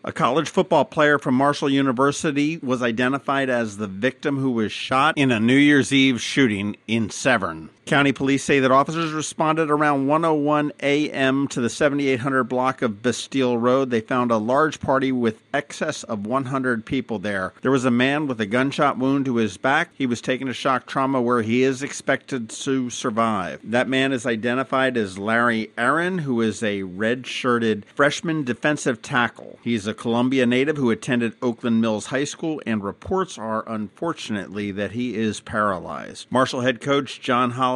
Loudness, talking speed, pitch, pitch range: -21 LUFS, 175 wpm, 130 Hz, 115-140 Hz